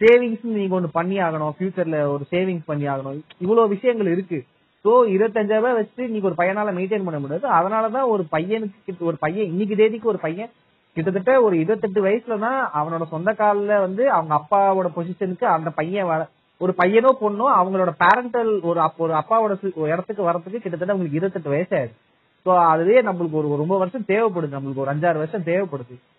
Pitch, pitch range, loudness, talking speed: 185 Hz, 165-215 Hz, -21 LUFS, 165 wpm